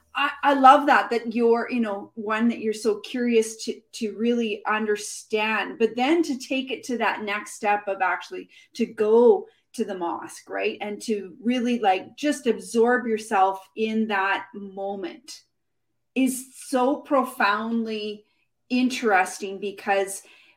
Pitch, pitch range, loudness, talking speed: 225 Hz, 205-255 Hz, -24 LUFS, 140 wpm